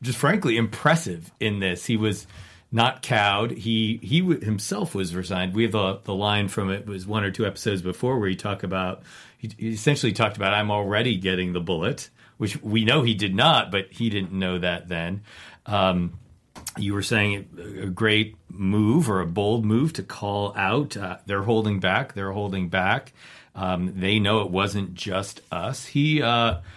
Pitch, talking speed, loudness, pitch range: 100 Hz, 190 wpm, -24 LUFS, 95-115 Hz